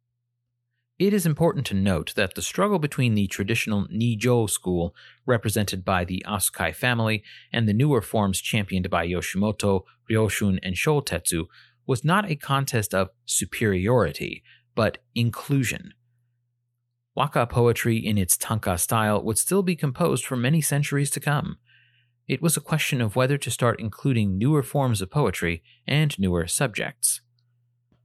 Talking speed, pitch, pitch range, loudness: 145 wpm, 120 Hz, 100-135 Hz, -24 LUFS